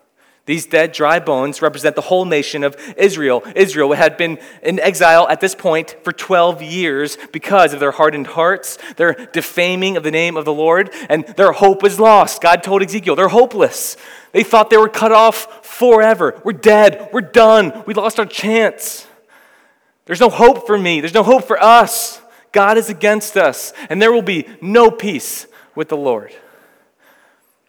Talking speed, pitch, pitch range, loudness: 180 wpm, 200 Hz, 165-225 Hz, -13 LUFS